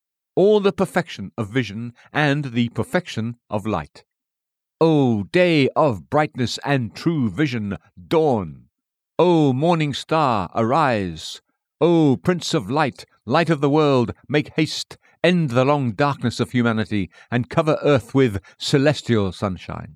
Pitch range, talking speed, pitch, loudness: 110-155 Hz, 130 wpm, 130 Hz, -20 LUFS